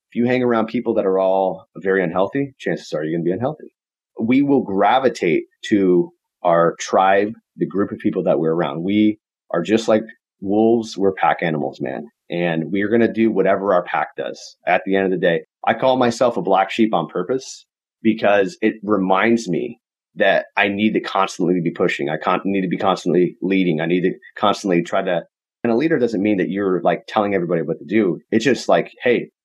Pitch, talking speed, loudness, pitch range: 100 Hz, 210 wpm, -19 LUFS, 90-110 Hz